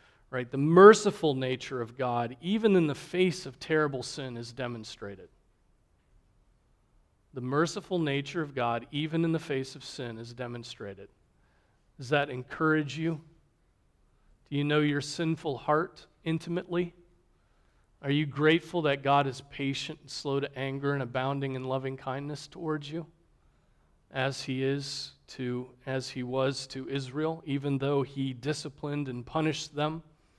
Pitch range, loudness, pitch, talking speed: 130-155 Hz, -30 LUFS, 140 Hz, 145 wpm